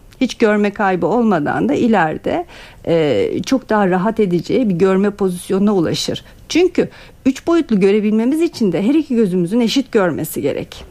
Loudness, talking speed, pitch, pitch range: -16 LUFS, 150 wpm, 220 Hz, 195-265 Hz